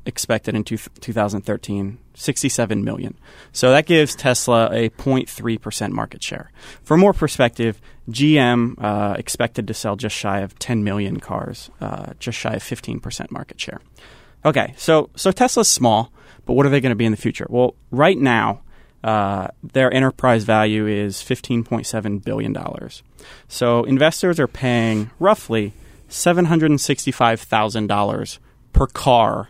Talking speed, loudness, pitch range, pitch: 140 wpm, -19 LUFS, 110-135 Hz, 120 Hz